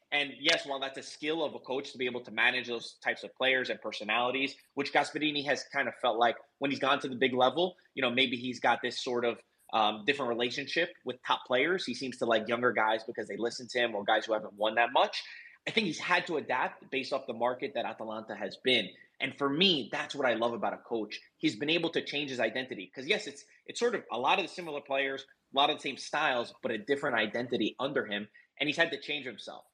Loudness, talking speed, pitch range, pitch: -31 LUFS, 255 wpm, 120-145 Hz, 130 Hz